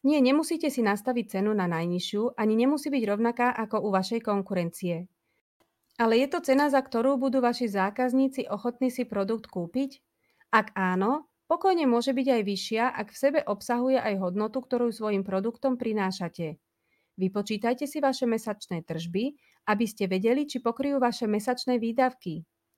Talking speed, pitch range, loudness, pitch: 155 wpm, 200-260 Hz, -27 LUFS, 230 Hz